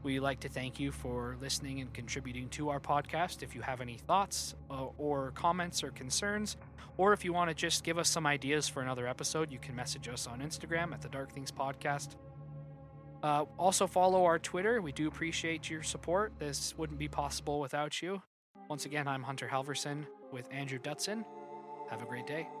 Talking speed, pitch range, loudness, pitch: 195 wpm, 135-160 Hz, -35 LUFS, 145 Hz